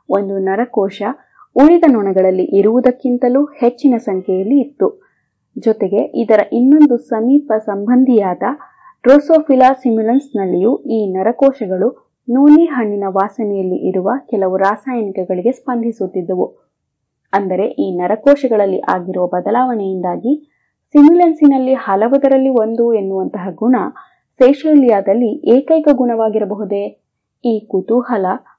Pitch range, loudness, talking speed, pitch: 195-270 Hz, -13 LUFS, 80 wpm, 230 Hz